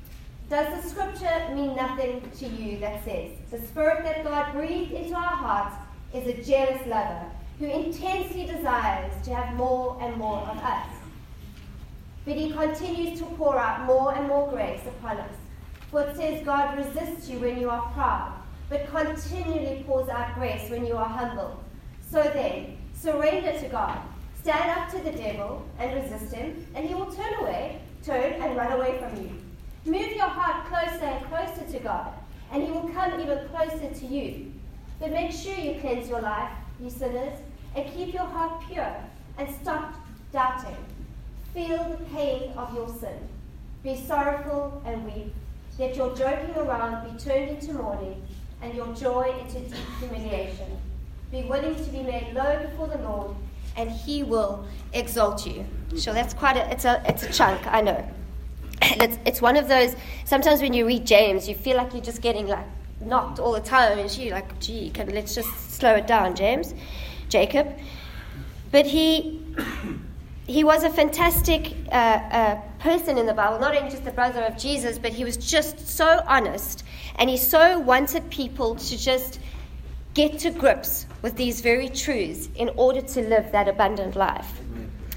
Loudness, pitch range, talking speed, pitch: -25 LUFS, 235-310 Hz, 175 wpm, 265 Hz